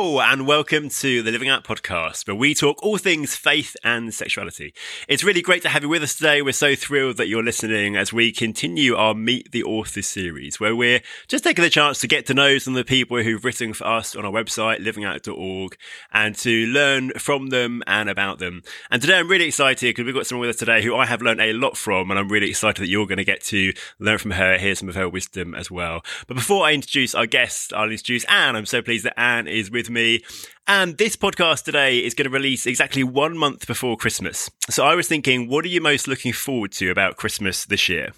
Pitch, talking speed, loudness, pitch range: 120 Hz, 240 wpm, -19 LUFS, 105-145 Hz